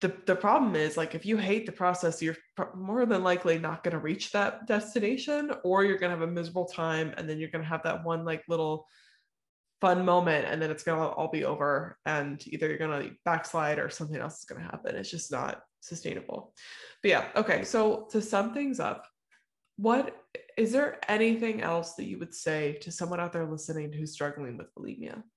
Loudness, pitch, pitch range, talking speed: -30 LUFS, 170 Hz, 160-210 Hz, 215 wpm